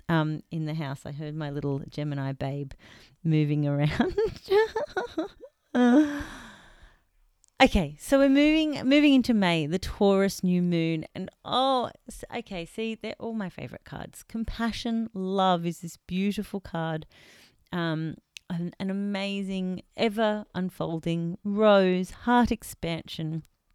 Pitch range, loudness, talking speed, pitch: 160-230 Hz, -27 LUFS, 120 wpm, 185 Hz